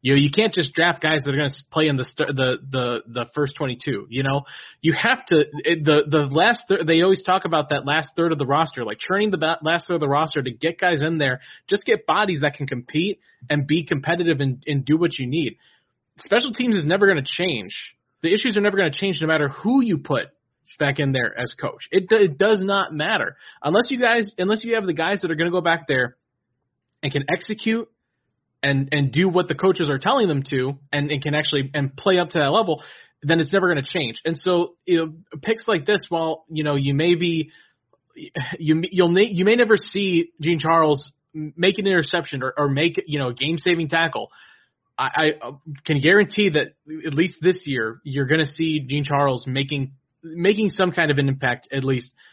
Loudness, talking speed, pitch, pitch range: -21 LUFS, 225 wpm, 160 Hz, 140-180 Hz